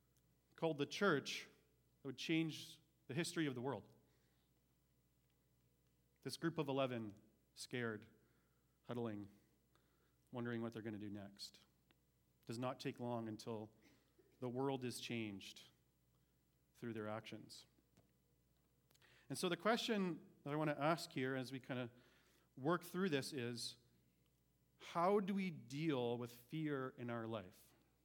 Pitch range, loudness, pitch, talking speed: 100-145 Hz, -45 LUFS, 120 Hz, 135 wpm